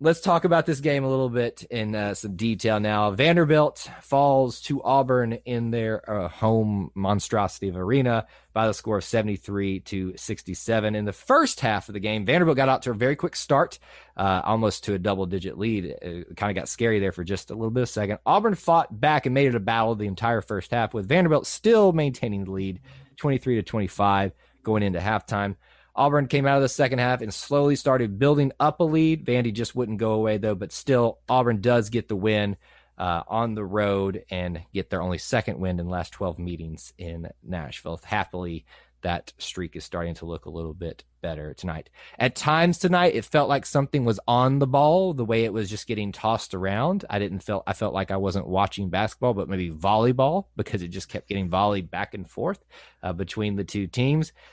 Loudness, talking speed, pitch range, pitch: -24 LUFS, 210 wpm, 95-130 Hz, 110 Hz